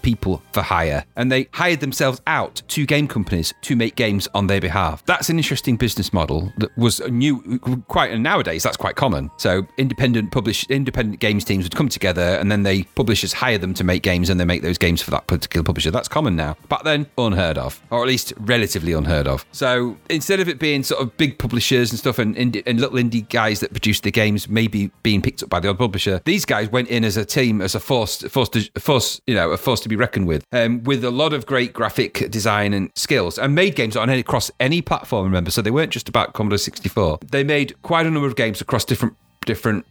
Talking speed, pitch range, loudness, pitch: 235 wpm, 100-130 Hz, -19 LUFS, 115 Hz